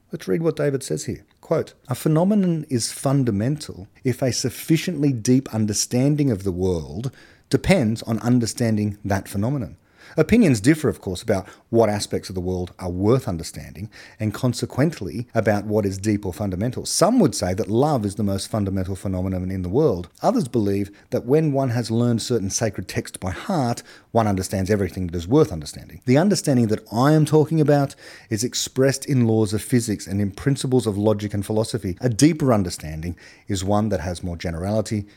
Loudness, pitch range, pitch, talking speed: -22 LUFS, 100-135 Hz, 110 Hz, 180 wpm